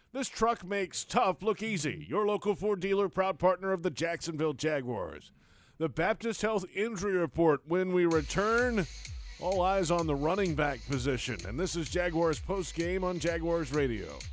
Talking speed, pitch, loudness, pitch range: 165 wpm, 175 Hz, -31 LUFS, 155-195 Hz